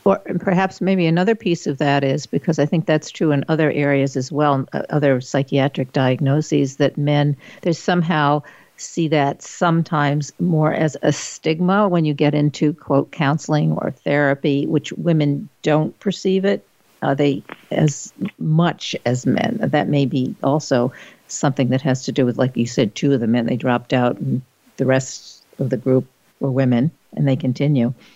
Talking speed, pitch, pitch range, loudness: 175 wpm, 145 Hz, 135-160 Hz, -19 LUFS